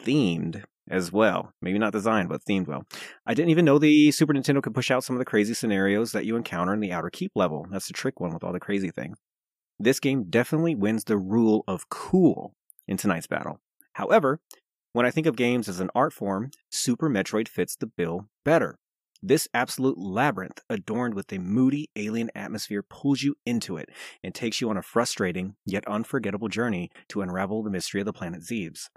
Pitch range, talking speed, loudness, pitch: 100-130 Hz, 205 wpm, -26 LUFS, 110 Hz